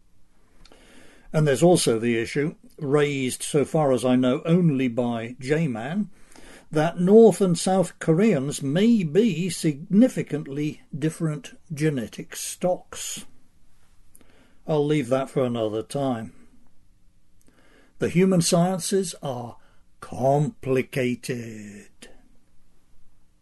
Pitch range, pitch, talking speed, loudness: 130-175 Hz, 150 Hz, 95 wpm, -23 LUFS